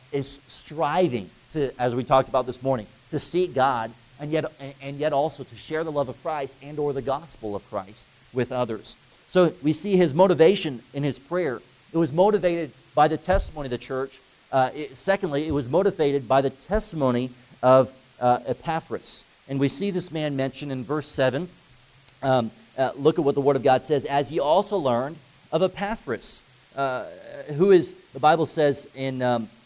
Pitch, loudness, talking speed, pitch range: 140 Hz, -24 LUFS, 185 wpm, 130-160 Hz